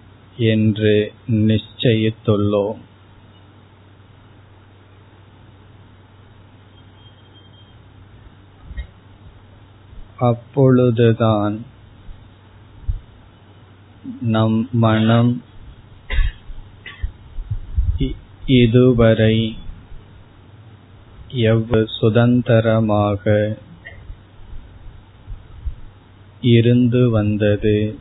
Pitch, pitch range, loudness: 105 Hz, 100-110 Hz, -17 LUFS